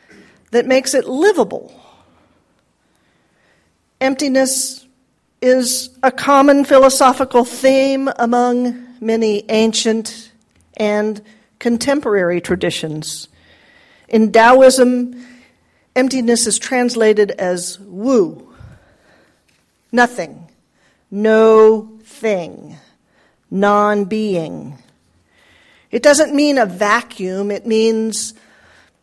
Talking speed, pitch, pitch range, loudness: 70 wpm, 235 Hz, 215-260 Hz, -14 LUFS